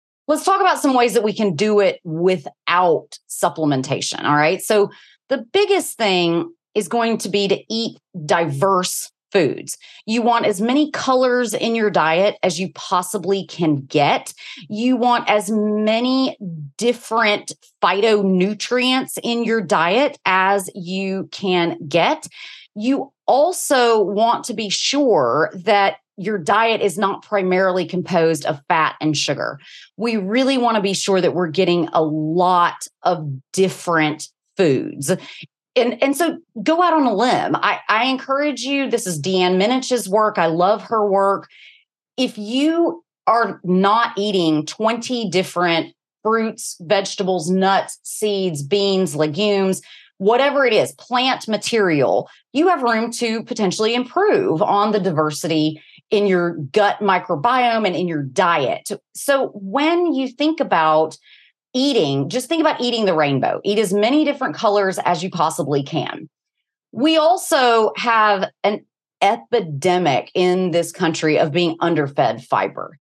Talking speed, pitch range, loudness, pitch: 140 wpm, 180-245 Hz, -18 LUFS, 205 Hz